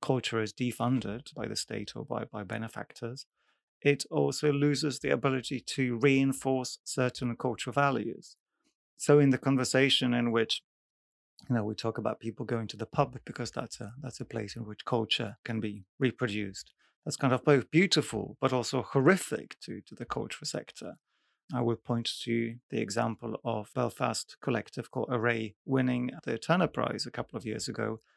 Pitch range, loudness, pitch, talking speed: 115-135 Hz, -31 LUFS, 125 Hz, 175 wpm